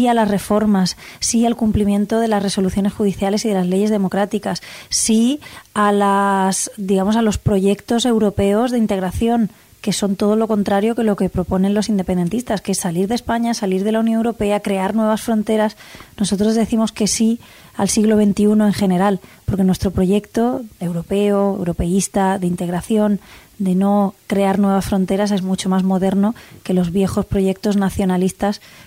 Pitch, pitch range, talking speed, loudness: 205 Hz, 195-215 Hz, 165 wpm, -18 LUFS